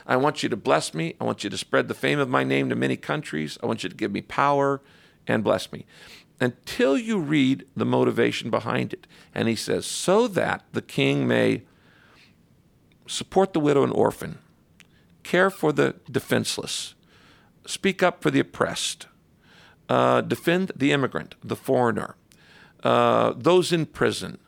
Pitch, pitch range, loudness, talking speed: 140 Hz, 115-175 Hz, -24 LUFS, 165 wpm